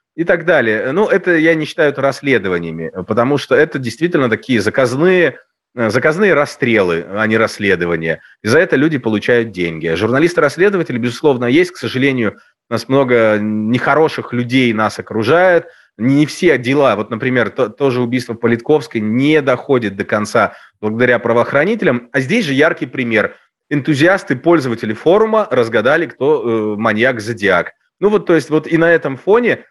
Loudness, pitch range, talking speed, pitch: -14 LUFS, 110-150 Hz, 150 wpm, 125 Hz